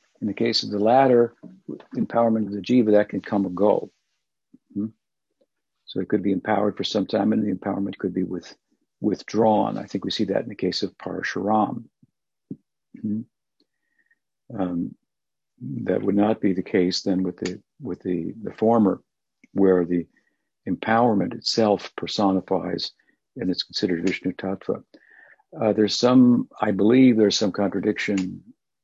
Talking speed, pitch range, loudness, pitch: 155 wpm, 95-110 Hz, -23 LUFS, 100 Hz